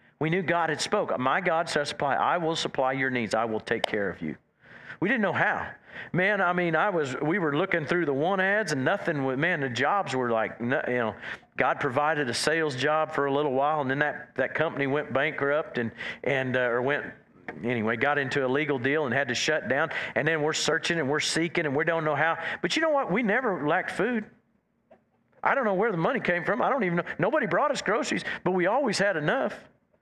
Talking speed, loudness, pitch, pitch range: 240 wpm, -26 LUFS, 150 Hz, 130-165 Hz